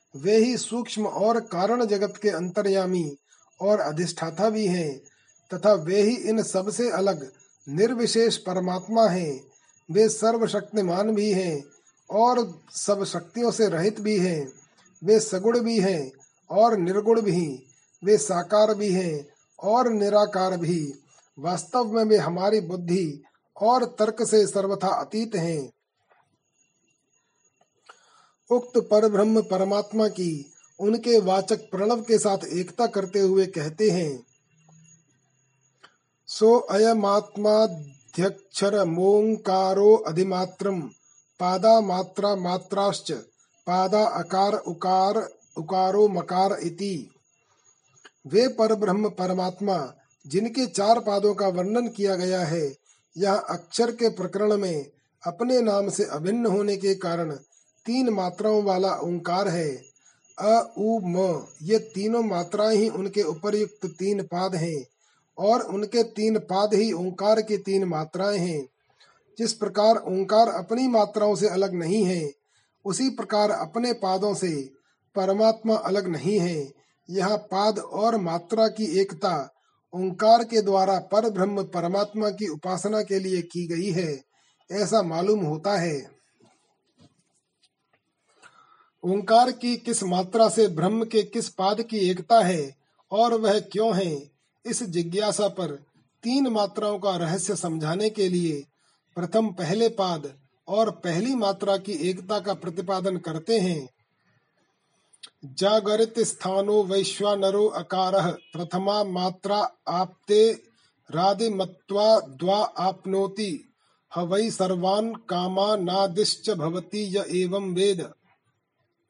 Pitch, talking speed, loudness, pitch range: 195 Hz, 115 wpm, -24 LUFS, 180-215 Hz